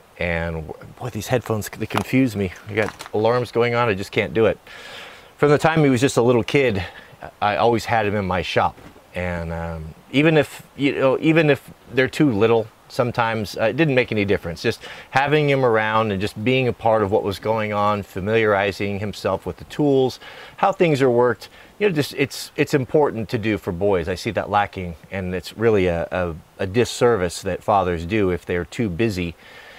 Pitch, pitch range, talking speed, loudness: 110 Hz, 95-130 Hz, 205 wpm, -20 LUFS